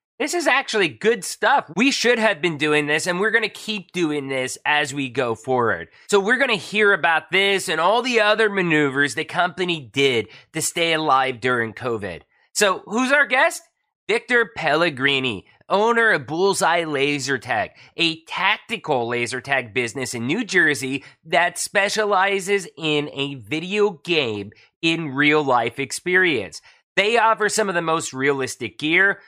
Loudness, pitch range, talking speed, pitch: -20 LUFS, 140-205 Hz, 160 wpm, 165 Hz